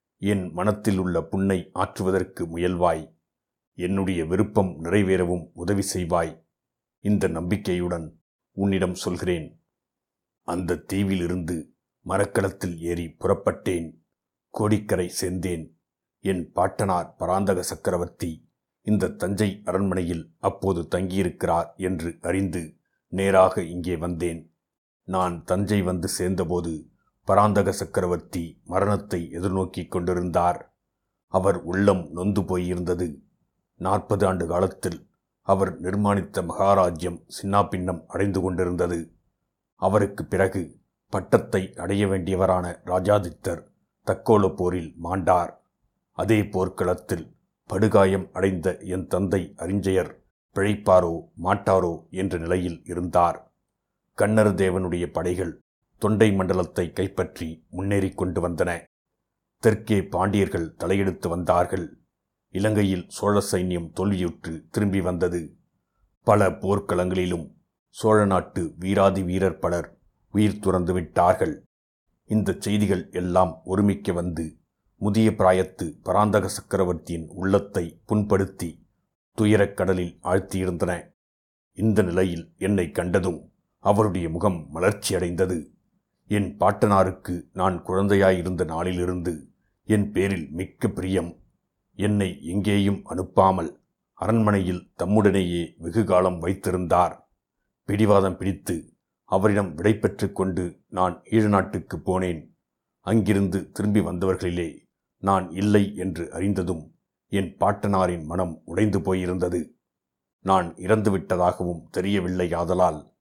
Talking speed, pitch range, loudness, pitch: 90 wpm, 90-100 Hz, -24 LUFS, 95 Hz